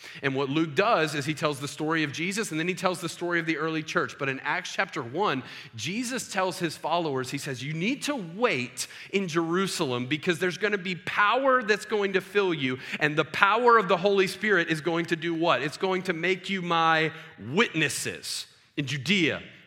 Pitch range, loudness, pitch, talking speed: 155-190 Hz, -26 LUFS, 170 Hz, 215 wpm